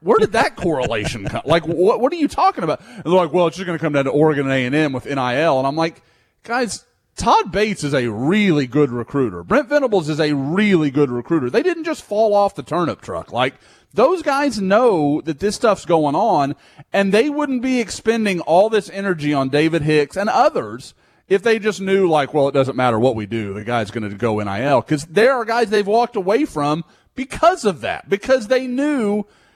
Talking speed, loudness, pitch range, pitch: 220 wpm, -18 LUFS, 145-215 Hz, 170 Hz